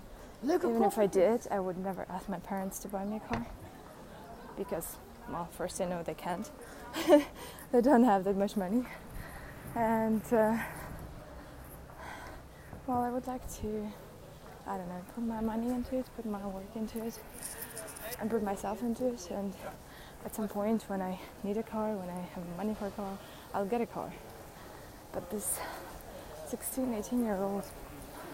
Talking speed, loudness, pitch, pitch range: 165 wpm, -34 LUFS, 215 Hz, 195-235 Hz